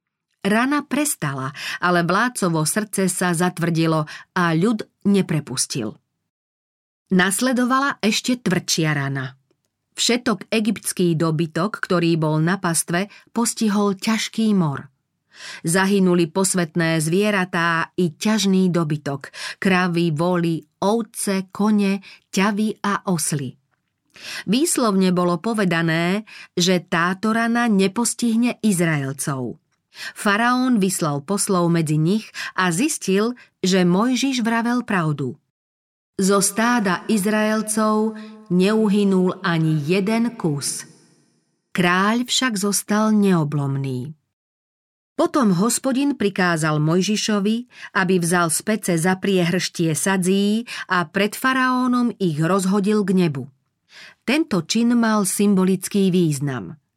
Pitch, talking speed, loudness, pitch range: 190 Hz, 95 wpm, -20 LUFS, 170-215 Hz